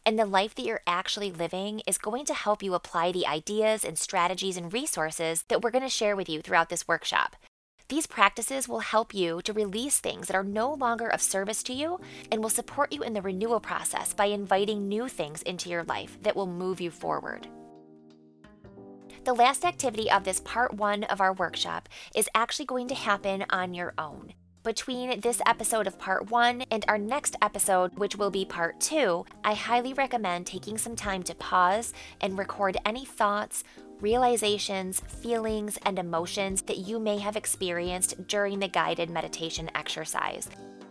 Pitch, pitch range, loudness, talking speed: 205 Hz, 180-225 Hz, -28 LUFS, 180 wpm